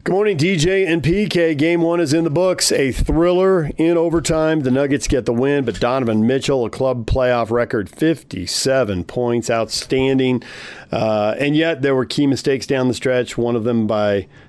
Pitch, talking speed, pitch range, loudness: 135 Hz, 180 wpm, 120-165 Hz, -17 LUFS